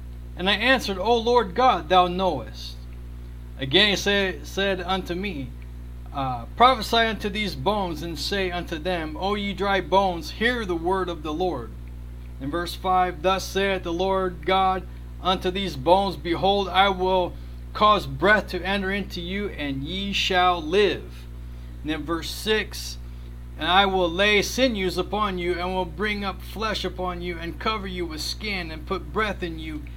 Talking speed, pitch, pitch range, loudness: 170 wpm, 185 Hz, 155-195 Hz, -23 LUFS